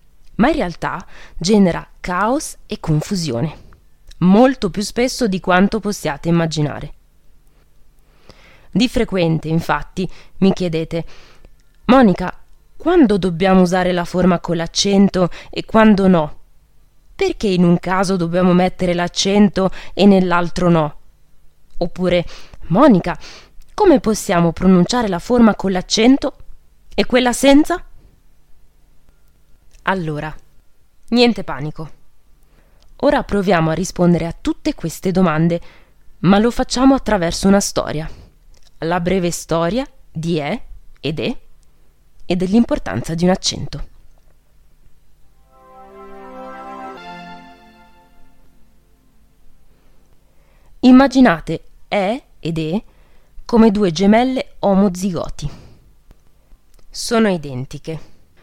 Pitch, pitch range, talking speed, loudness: 180 Hz, 155-205 Hz, 95 wpm, -16 LUFS